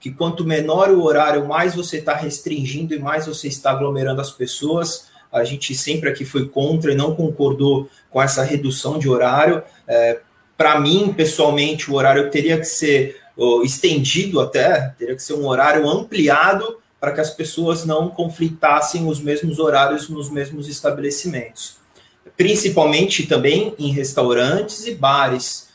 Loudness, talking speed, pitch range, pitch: -16 LUFS, 155 wpm, 140-160 Hz, 150 Hz